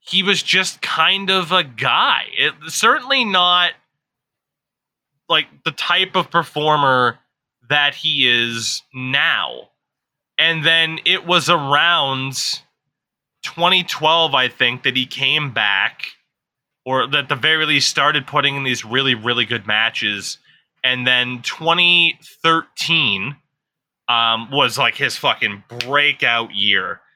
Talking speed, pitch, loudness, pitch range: 120 wpm, 145 Hz, -16 LUFS, 125-170 Hz